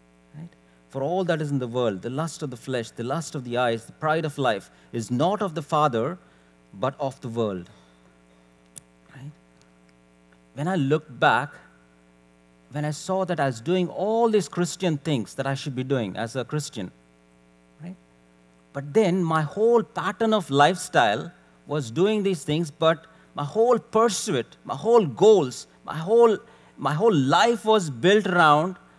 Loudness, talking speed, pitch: -24 LUFS, 170 wpm, 145 Hz